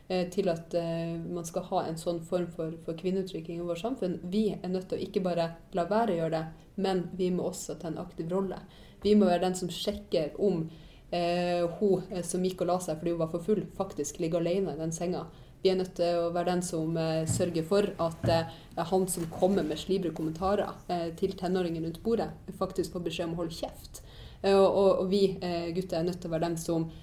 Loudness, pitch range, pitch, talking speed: -31 LUFS, 165-190 Hz, 175 Hz, 230 wpm